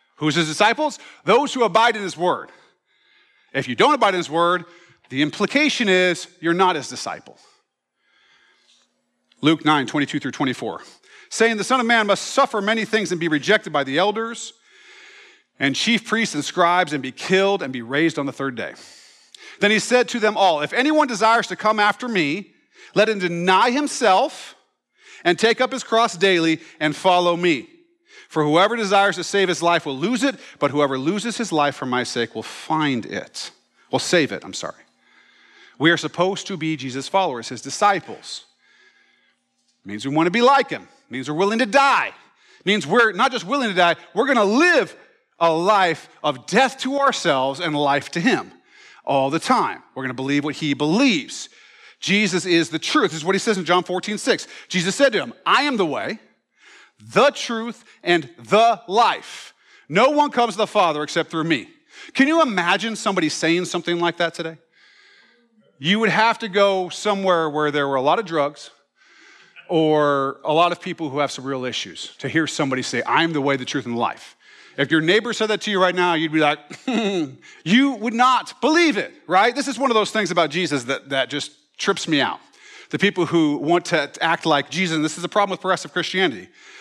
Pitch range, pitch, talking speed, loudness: 155-235 Hz, 185 Hz, 200 wpm, -20 LUFS